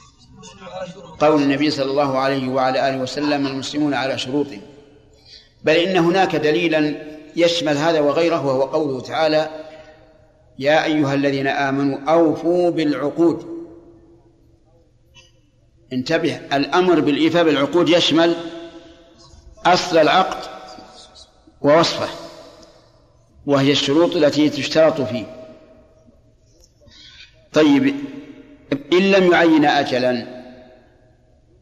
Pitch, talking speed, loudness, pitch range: 150 Hz, 85 wpm, -18 LUFS, 135-165 Hz